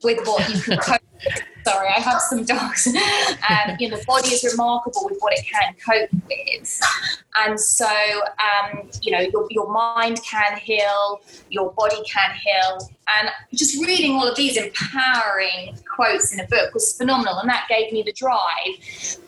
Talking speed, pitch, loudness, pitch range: 175 wpm, 220 Hz, -19 LUFS, 205-255 Hz